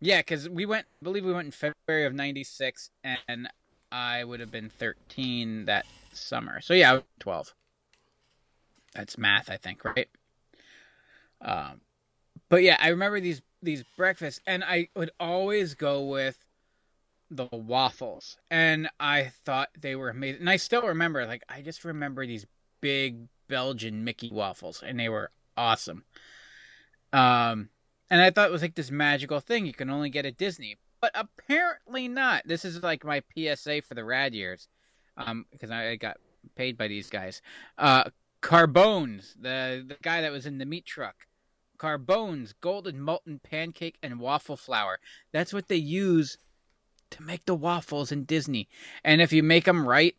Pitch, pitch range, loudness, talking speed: 150 Hz, 130-175 Hz, -27 LUFS, 165 wpm